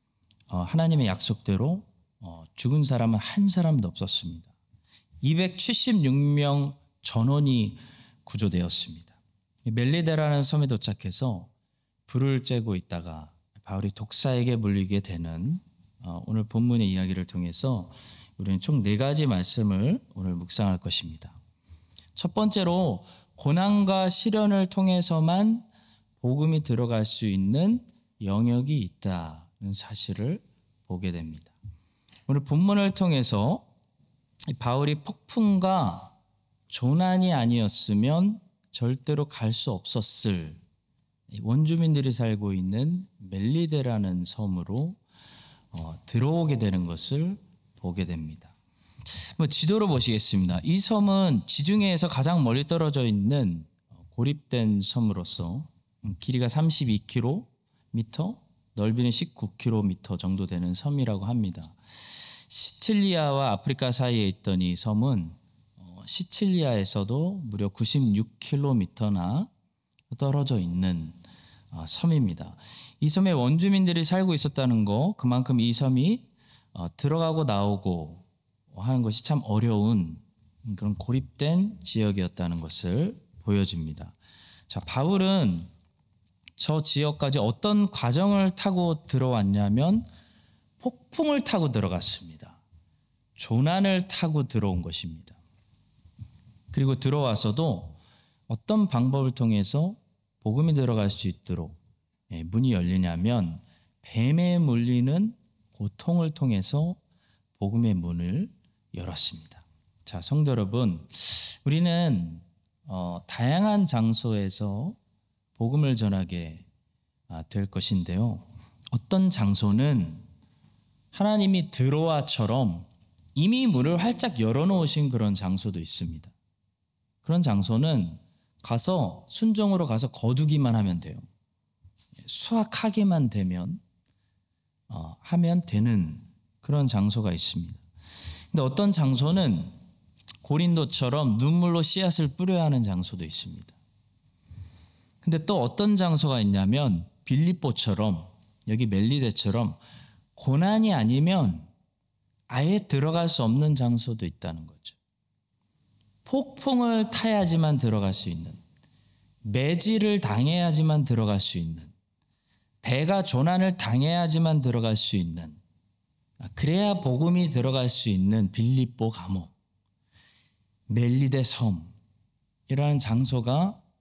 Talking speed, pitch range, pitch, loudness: 235 characters per minute, 95-150 Hz, 115 Hz, -26 LUFS